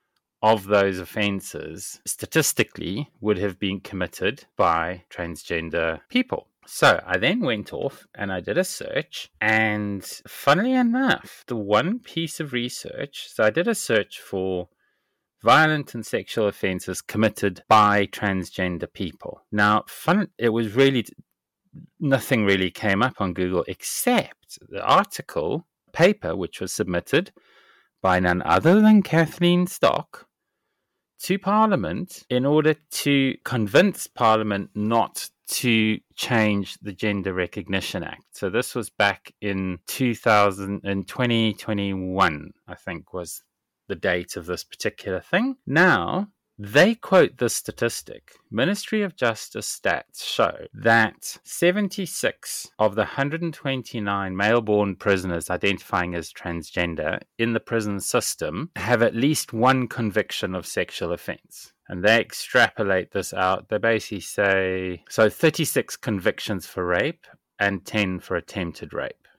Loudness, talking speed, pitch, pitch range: -23 LUFS, 130 wpm, 110 Hz, 100-155 Hz